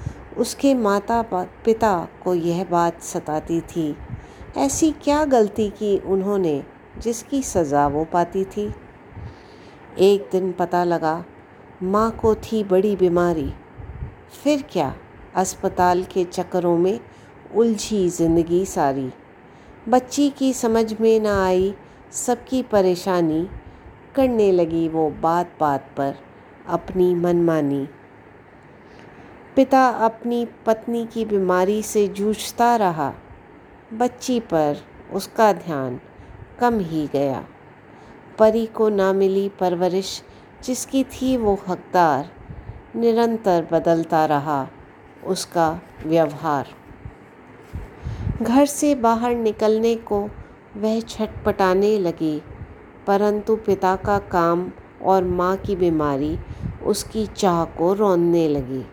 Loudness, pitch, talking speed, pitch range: -21 LUFS, 190 Hz, 105 wpm, 165-220 Hz